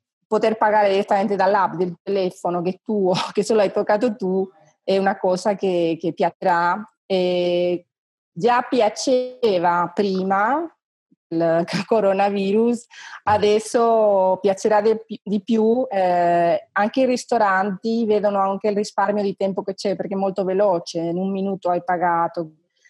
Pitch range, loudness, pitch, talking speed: 180-215 Hz, -20 LUFS, 195 Hz, 130 wpm